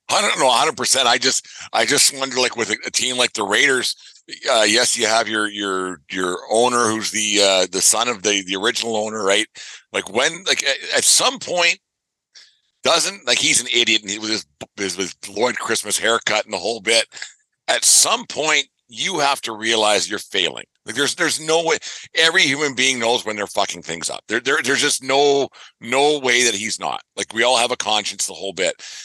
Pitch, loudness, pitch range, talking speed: 115 Hz, -17 LUFS, 105-135 Hz, 205 wpm